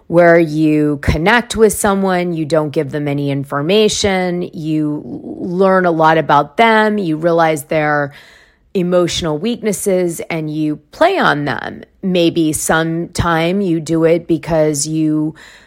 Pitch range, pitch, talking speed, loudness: 155-185 Hz, 165 Hz, 130 wpm, -14 LUFS